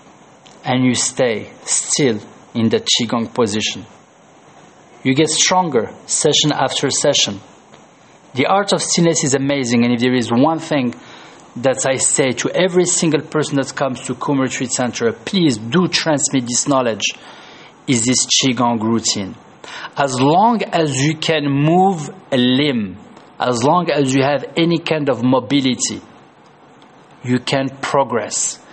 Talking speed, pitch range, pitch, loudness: 140 wpm, 125-160 Hz, 140 Hz, -16 LUFS